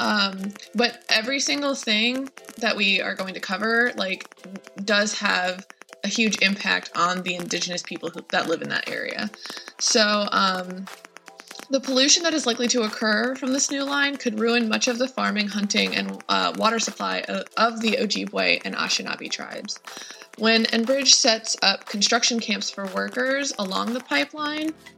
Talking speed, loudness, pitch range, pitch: 165 wpm, -22 LUFS, 195-255 Hz, 225 Hz